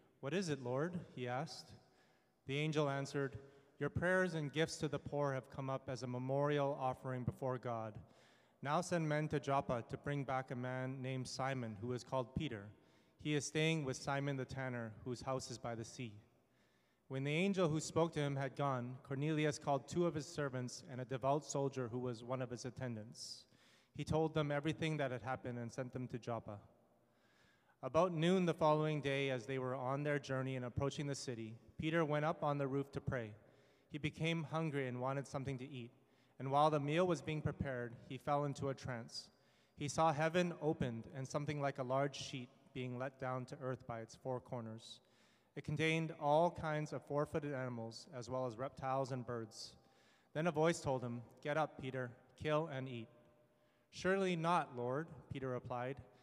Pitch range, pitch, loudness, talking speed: 125-150 Hz, 135 Hz, -41 LUFS, 195 wpm